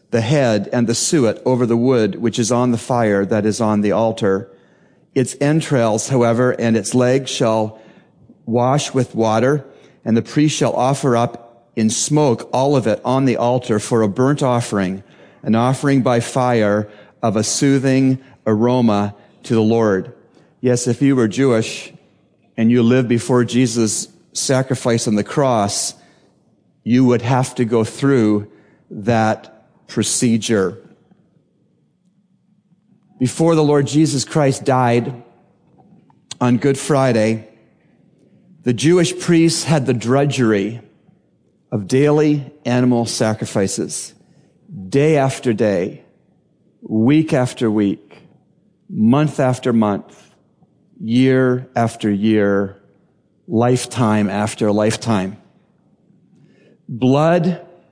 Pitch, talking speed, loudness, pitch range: 125 Hz, 120 wpm, -17 LUFS, 110-140 Hz